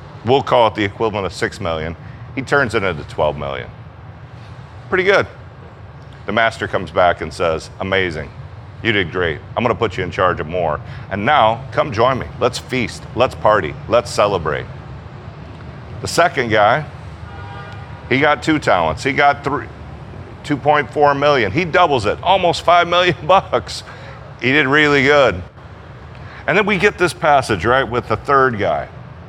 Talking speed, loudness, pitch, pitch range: 165 wpm, -16 LUFS, 130 Hz, 105-145 Hz